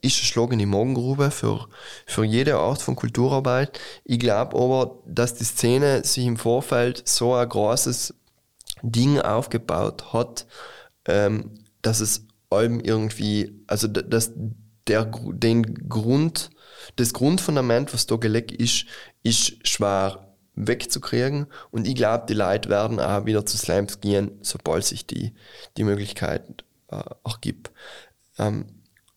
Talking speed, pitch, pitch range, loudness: 125 wpm, 115 Hz, 105-125 Hz, -23 LUFS